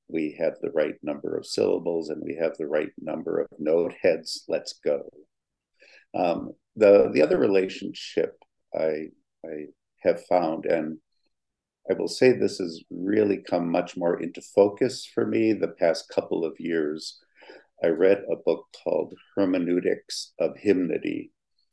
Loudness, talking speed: -26 LUFS, 150 wpm